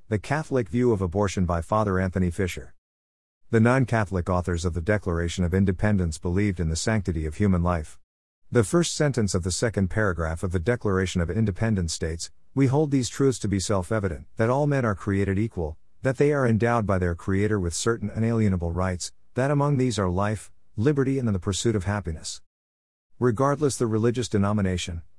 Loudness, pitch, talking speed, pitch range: -25 LUFS, 100 Hz, 185 wpm, 90-115 Hz